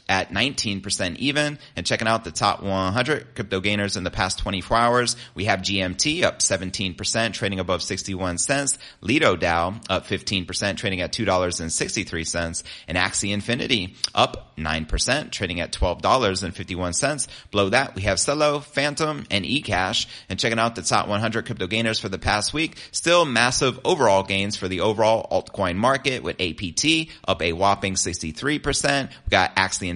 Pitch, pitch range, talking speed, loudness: 100 Hz, 95-120 Hz, 155 wpm, -22 LUFS